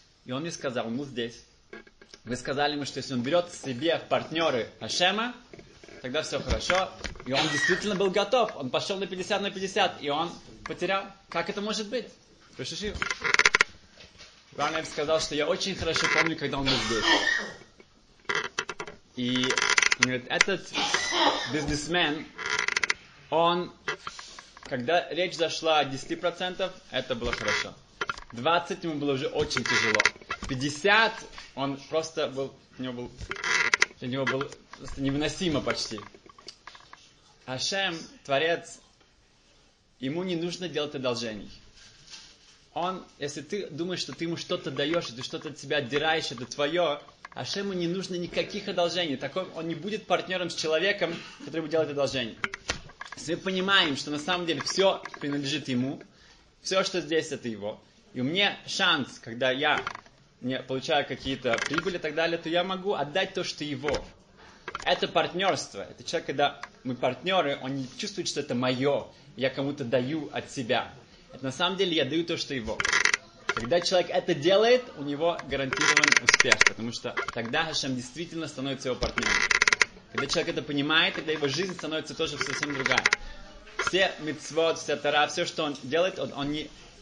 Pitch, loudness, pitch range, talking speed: 155 Hz, -27 LUFS, 140-180 Hz, 155 wpm